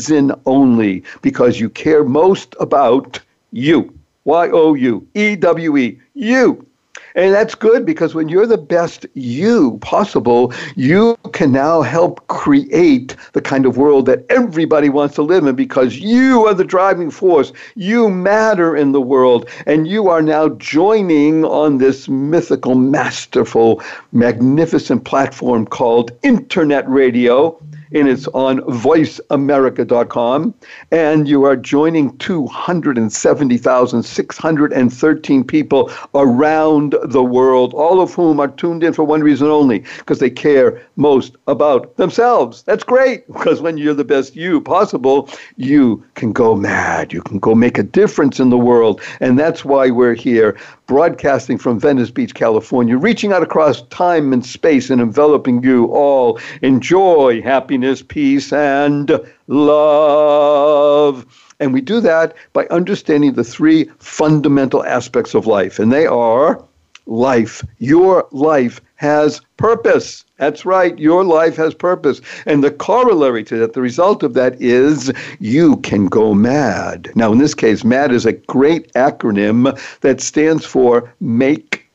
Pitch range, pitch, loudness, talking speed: 130-170 Hz, 150 Hz, -13 LUFS, 140 wpm